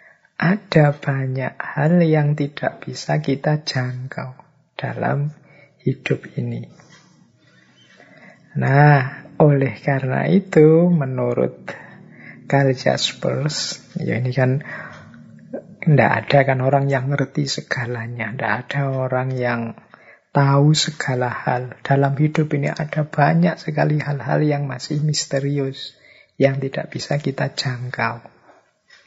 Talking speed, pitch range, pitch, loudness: 105 wpm, 130-150 Hz, 140 Hz, -19 LUFS